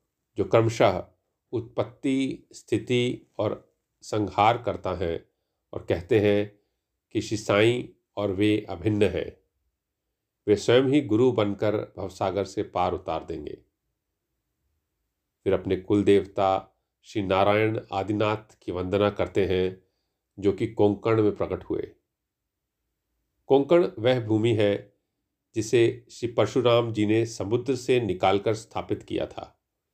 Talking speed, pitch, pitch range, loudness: 120 wpm, 105 Hz, 95-115 Hz, -25 LUFS